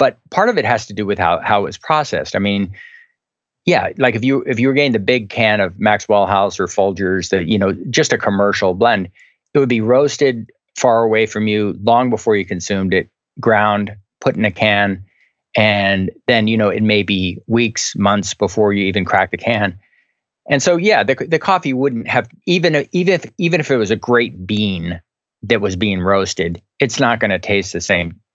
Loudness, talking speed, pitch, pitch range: -16 LUFS, 215 wpm, 105 Hz, 100-125 Hz